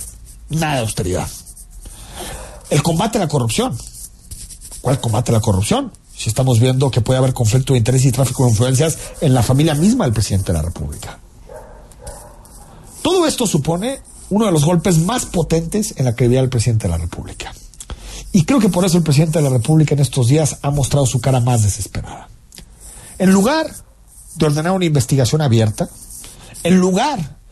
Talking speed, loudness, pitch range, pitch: 175 wpm, -16 LUFS, 115-165 Hz, 135 Hz